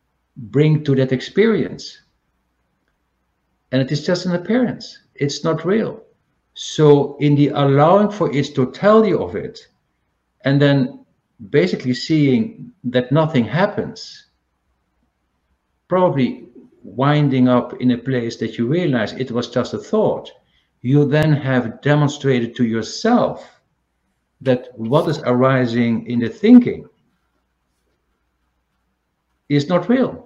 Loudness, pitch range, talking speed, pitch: -17 LUFS, 115-155 Hz, 115 wpm, 130 Hz